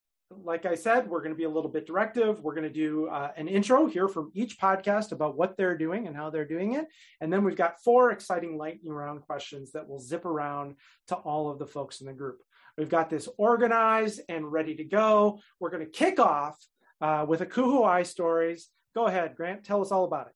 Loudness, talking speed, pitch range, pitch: -28 LUFS, 230 wpm, 155-200 Hz, 170 Hz